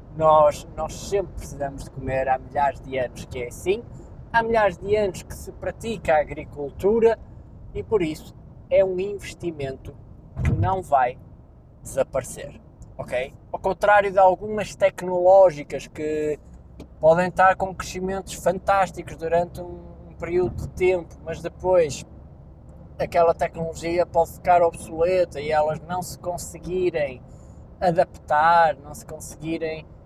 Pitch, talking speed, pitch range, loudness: 170 Hz, 130 wpm, 150-190 Hz, -23 LUFS